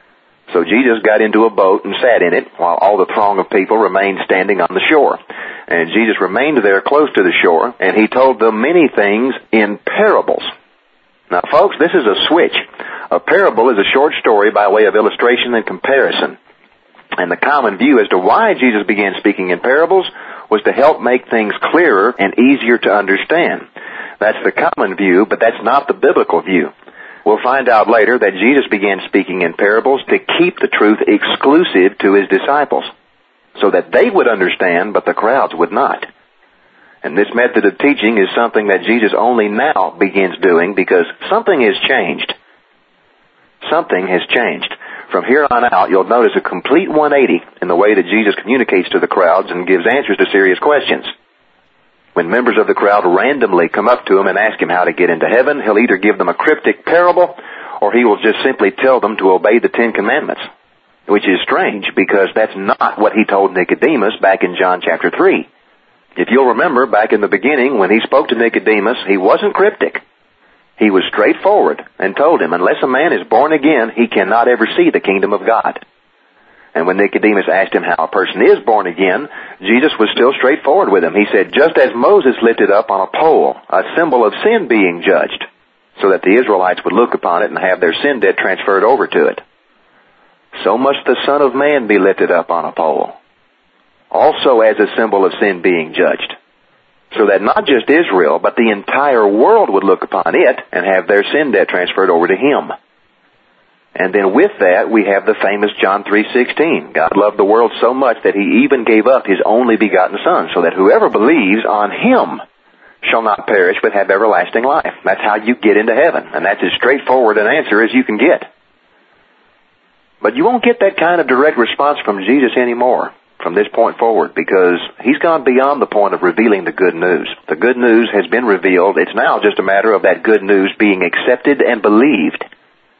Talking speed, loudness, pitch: 200 wpm, -12 LUFS, 120 Hz